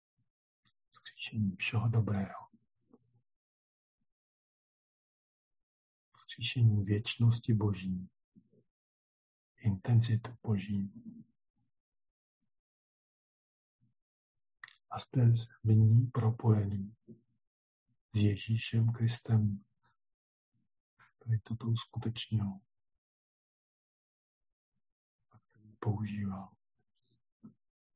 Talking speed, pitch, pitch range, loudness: 40 wpm, 110 Hz, 95-115 Hz, -33 LUFS